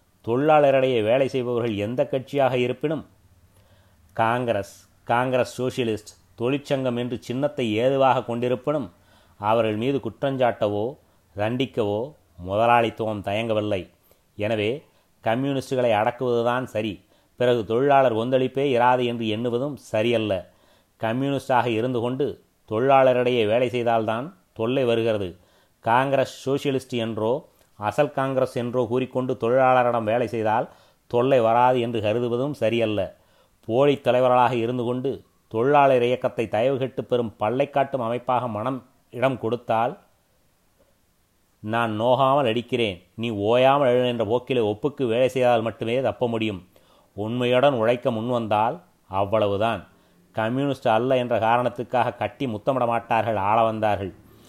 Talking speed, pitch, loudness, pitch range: 100 wpm, 120 Hz, -23 LUFS, 110-130 Hz